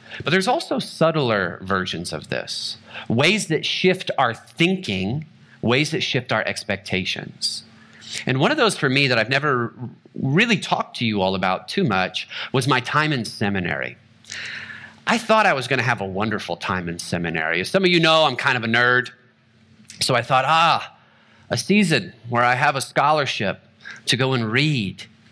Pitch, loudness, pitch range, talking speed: 120 Hz, -20 LUFS, 100-150 Hz, 180 wpm